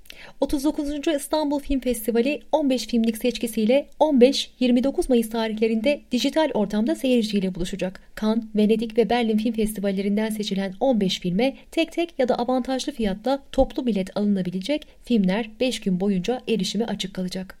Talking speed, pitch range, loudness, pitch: 135 wpm, 210-270 Hz, -23 LUFS, 235 Hz